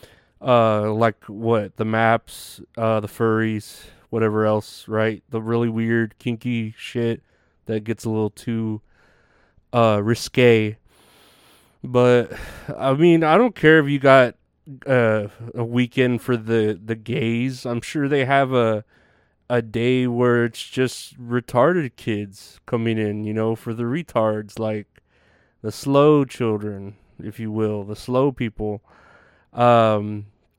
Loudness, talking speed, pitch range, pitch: -20 LUFS, 135 wpm, 110-125 Hz, 115 Hz